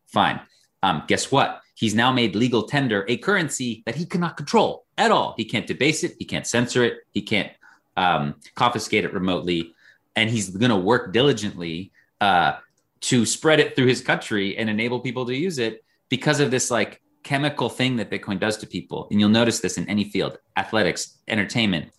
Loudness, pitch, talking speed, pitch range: -22 LUFS, 115 Hz, 190 wpm, 105-130 Hz